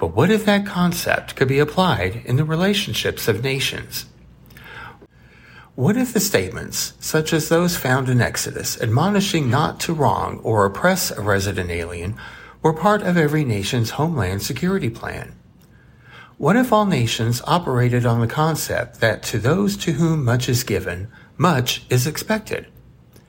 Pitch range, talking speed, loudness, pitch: 115-175 Hz, 150 wpm, -20 LUFS, 135 Hz